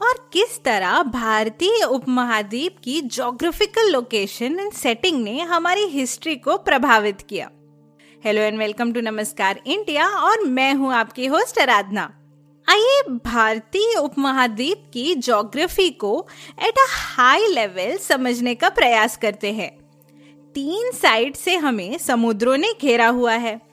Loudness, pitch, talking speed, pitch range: -19 LUFS, 250 Hz, 130 wpm, 220-335 Hz